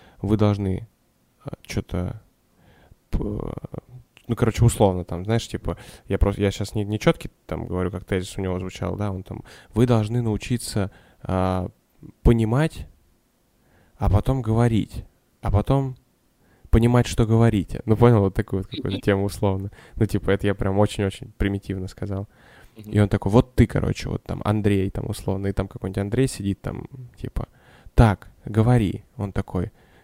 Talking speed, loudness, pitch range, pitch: 155 wpm, -23 LUFS, 95-120 Hz, 105 Hz